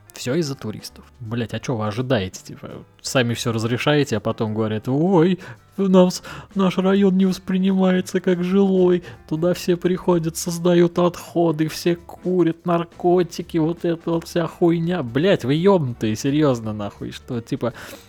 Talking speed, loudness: 145 wpm, -20 LUFS